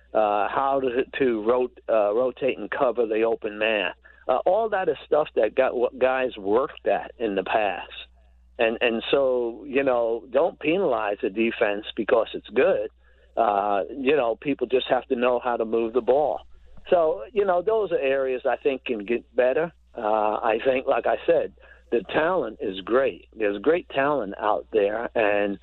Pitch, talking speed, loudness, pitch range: 120 Hz, 185 wpm, -24 LUFS, 110-140 Hz